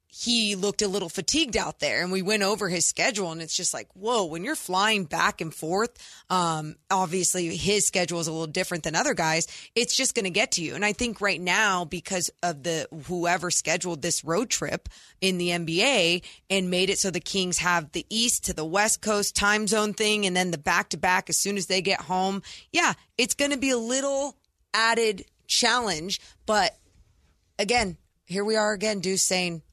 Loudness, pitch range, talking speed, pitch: -25 LUFS, 175-215 Hz, 210 wpm, 190 Hz